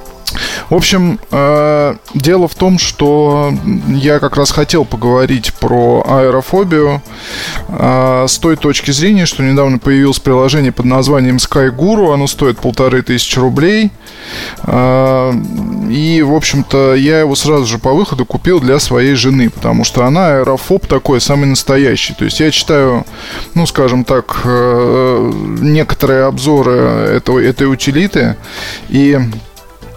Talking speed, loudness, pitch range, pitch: 130 wpm, -10 LUFS, 130-150 Hz, 135 Hz